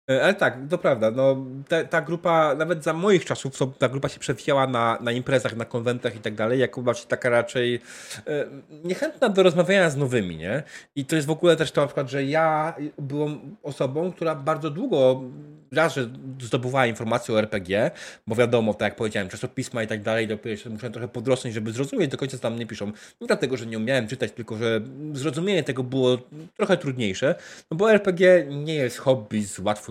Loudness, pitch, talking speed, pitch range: -24 LUFS, 130 Hz, 200 wpm, 120-155 Hz